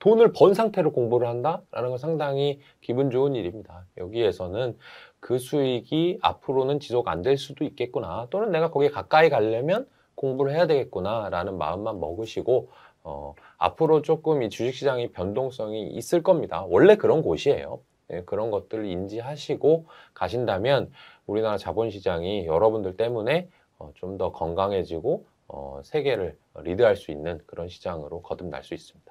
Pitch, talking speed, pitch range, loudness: 130 Hz, 355 characters per minute, 110-155 Hz, -25 LUFS